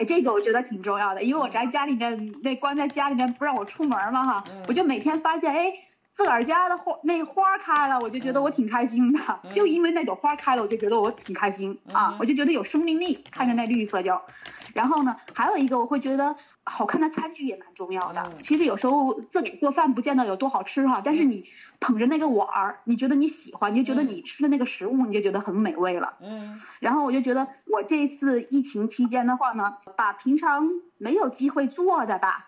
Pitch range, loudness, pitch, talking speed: 235-300 Hz, -24 LUFS, 270 Hz, 340 characters per minute